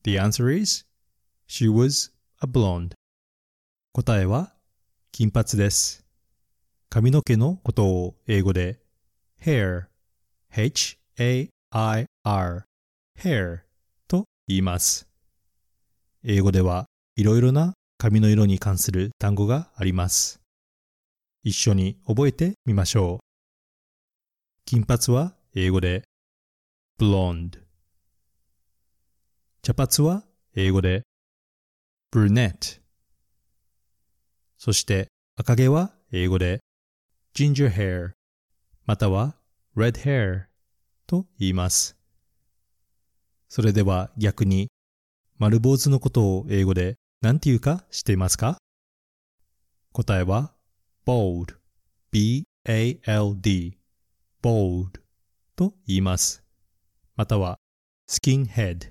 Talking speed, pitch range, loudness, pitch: 215 characters per minute, 90-120 Hz, -23 LUFS, 100 Hz